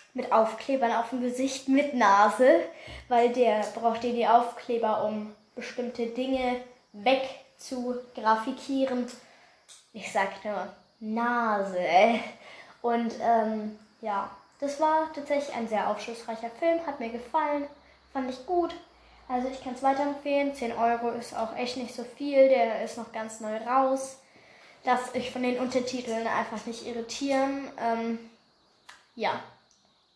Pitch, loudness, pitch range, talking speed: 245 Hz, -28 LUFS, 230-265 Hz, 135 wpm